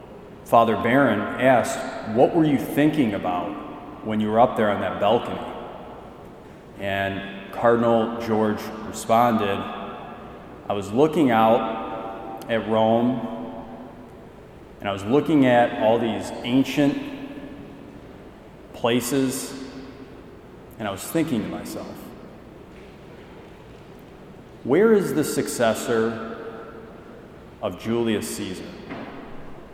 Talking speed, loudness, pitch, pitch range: 95 wpm, -22 LUFS, 115 Hz, 110-140 Hz